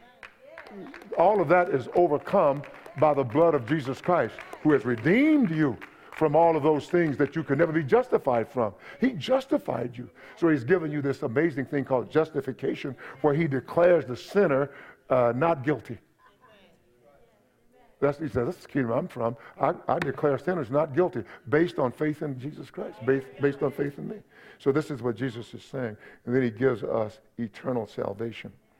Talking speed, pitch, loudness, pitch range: 180 wpm, 145 Hz, -26 LUFS, 130-165 Hz